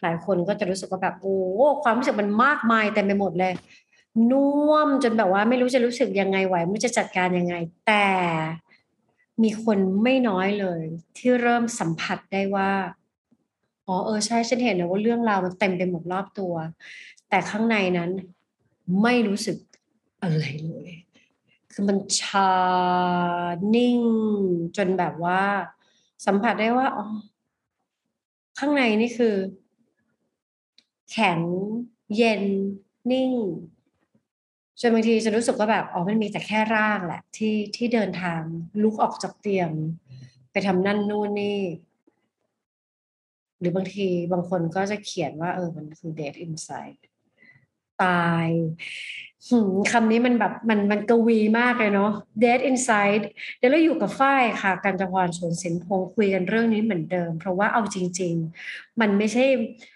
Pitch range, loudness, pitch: 180-230 Hz, -23 LUFS, 200 Hz